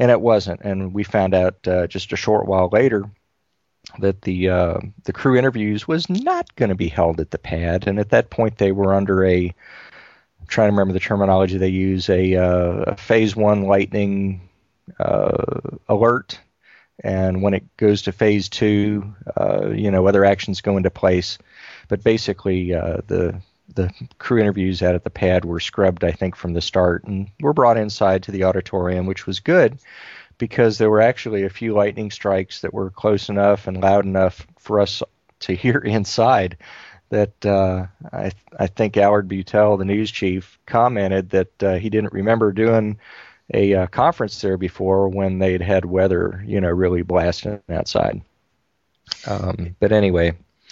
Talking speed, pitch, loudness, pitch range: 175 wpm, 95 Hz, -19 LUFS, 95-105 Hz